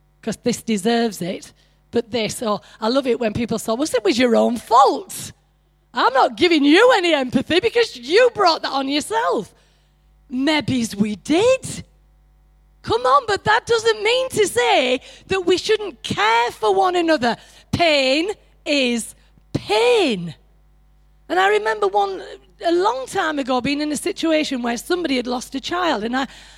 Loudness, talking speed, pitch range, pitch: -19 LUFS, 165 wpm, 240-400 Hz, 305 Hz